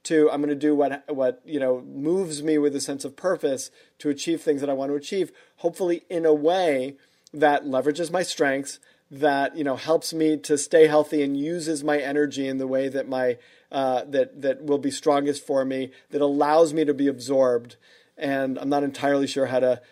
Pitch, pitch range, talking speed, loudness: 145 Hz, 135-155 Hz, 210 wpm, -24 LUFS